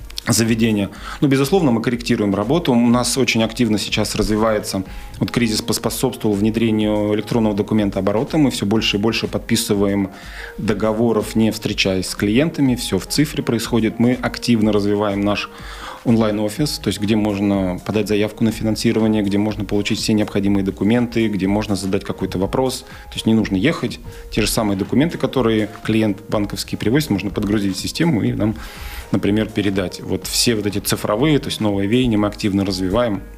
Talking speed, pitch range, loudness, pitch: 165 wpm, 100-115 Hz, -18 LUFS, 105 Hz